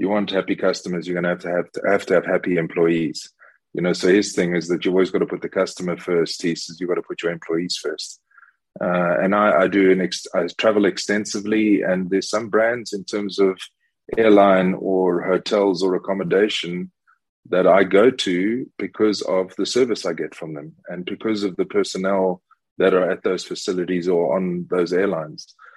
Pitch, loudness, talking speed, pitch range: 95 Hz, -20 LUFS, 205 wpm, 90-100 Hz